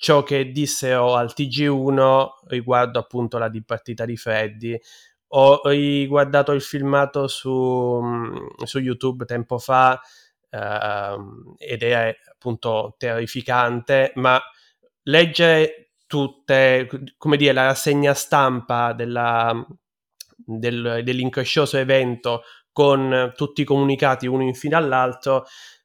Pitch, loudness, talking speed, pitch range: 130 Hz, -20 LUFS, 105 wpm, 120-140 Hz